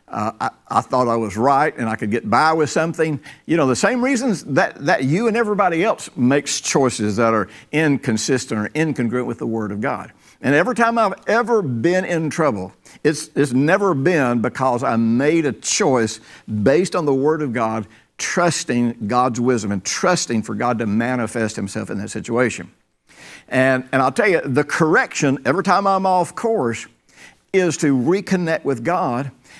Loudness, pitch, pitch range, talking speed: -19 LUFS, 140 Hz, 120-175 Hz, 180 wpm